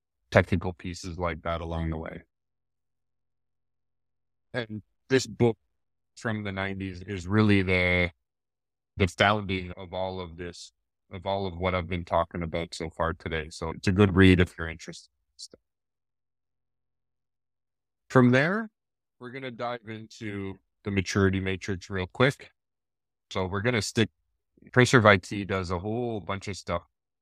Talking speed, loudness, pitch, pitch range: 150 wpm, -27 LUFS, 95 Hz, 85-105 Hz